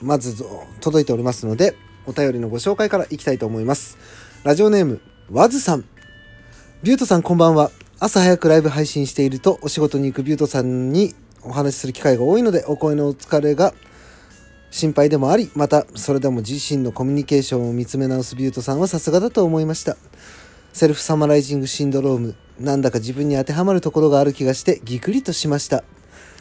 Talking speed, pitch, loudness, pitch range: 450 characters per minute, 140 Hz, -18 LUFS, 125-155 Hz